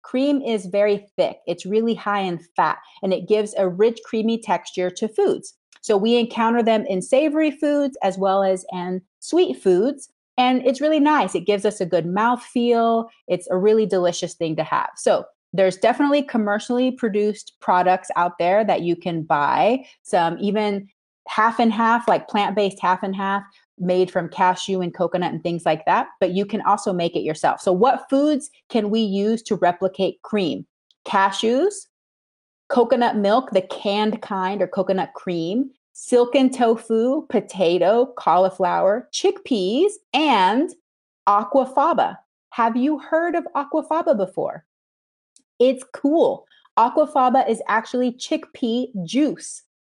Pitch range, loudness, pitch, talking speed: 190-260 Hz, -20 LUFS, 220 Hz, 150 wpm